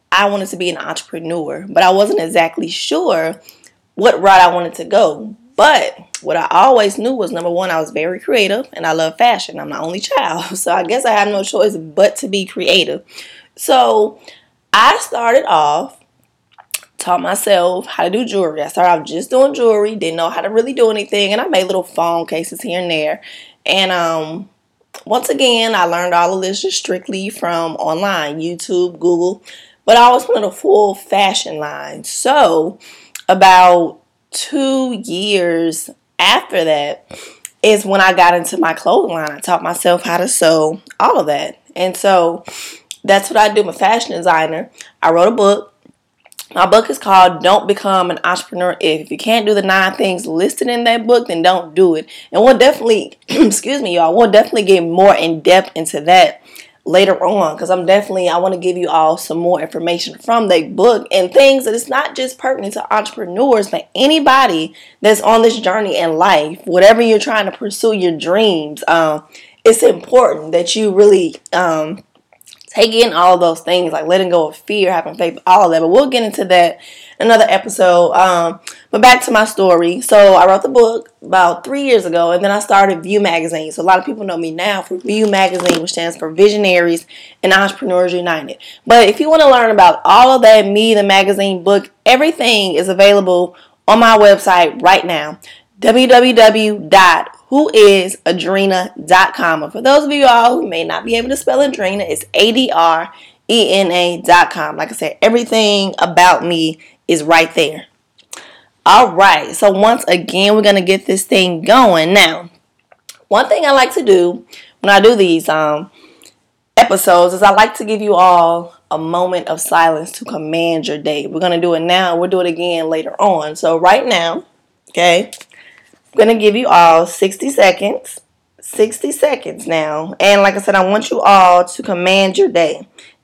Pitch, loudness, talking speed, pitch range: 190 Hz, -12 LUFS, 185 wpm, 170-220 Hz